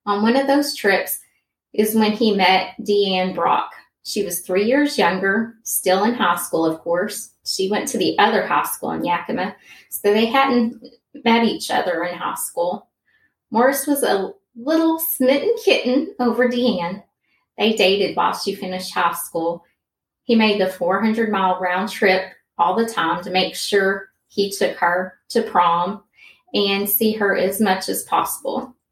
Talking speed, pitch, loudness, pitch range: 165 wpm, 205 Hz, -19 LUFS, 185-240 Hz